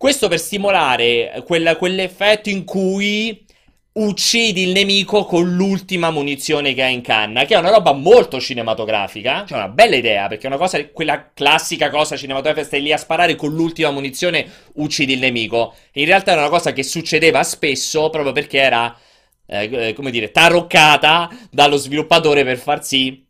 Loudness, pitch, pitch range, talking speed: -15 LUFS, 155 Hz, 135-185 Hz, 175 wpm